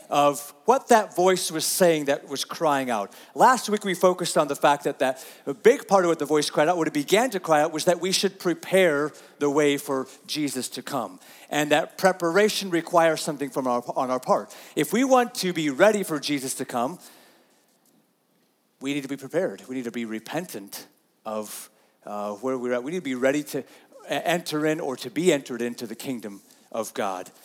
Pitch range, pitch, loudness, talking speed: 130-180 Hz, 150 Hz, -24 LUFS, 210 wpm